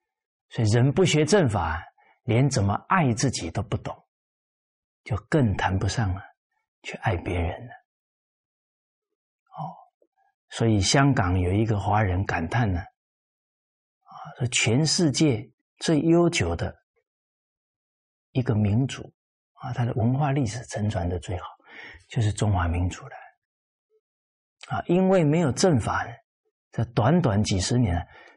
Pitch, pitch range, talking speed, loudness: 120 Hz, 100-160 Hz, 185 characters per minute, -24 LUFS